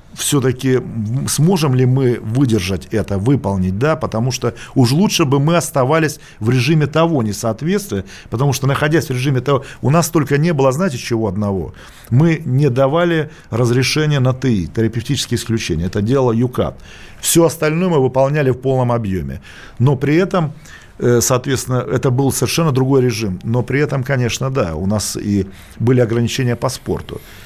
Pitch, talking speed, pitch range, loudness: 130 Hz, 155 wpm, 115-145 Hz, -16 LUFS